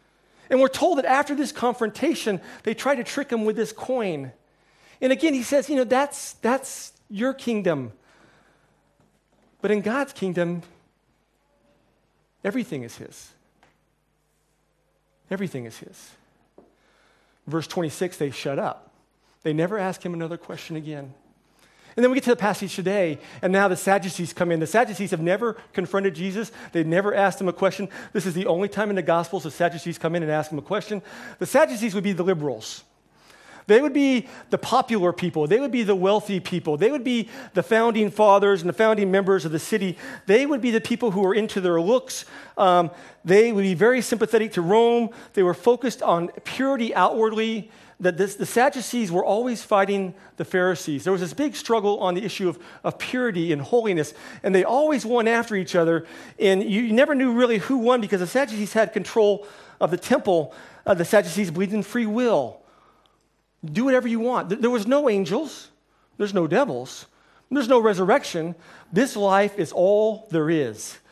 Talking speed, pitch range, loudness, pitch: 185 wpm, 180-240 Hz, -23 LUFS, 205 Hz